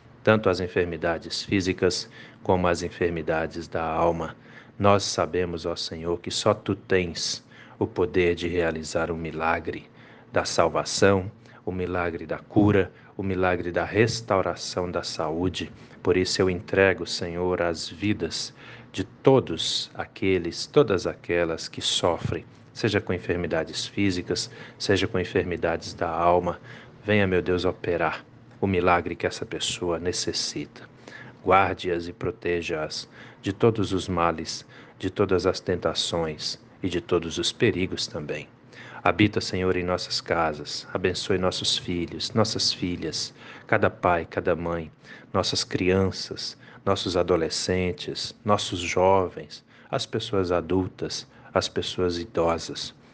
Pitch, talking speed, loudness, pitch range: 90 Hz, 125 wpm, -26 LUFS, 85-105 Hz